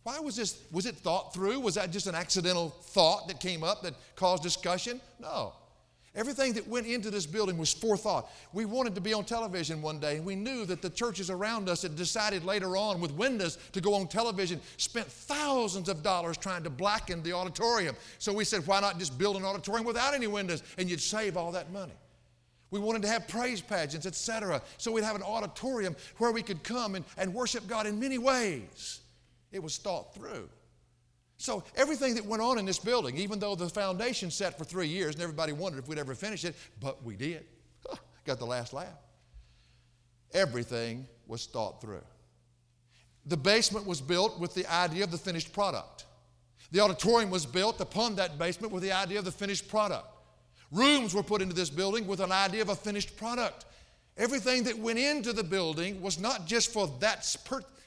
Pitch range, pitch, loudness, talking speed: 165-220 Hz, 190 Hz, -32 LUFS, 200 wpm